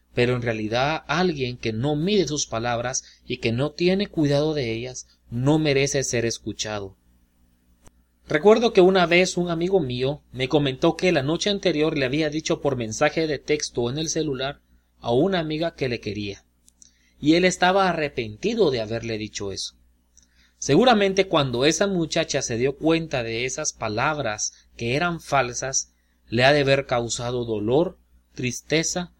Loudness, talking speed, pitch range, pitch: -23 LUFS, 160 wpm, 110-160 Hz, 135 Hz